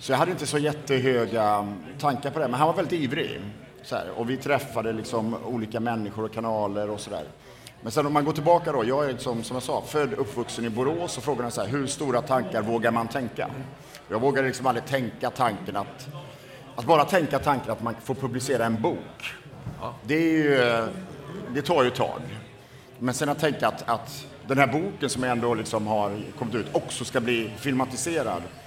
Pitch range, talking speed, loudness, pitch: 115-145 Hz, 205 wpm, -26 LUFS, 130 Hz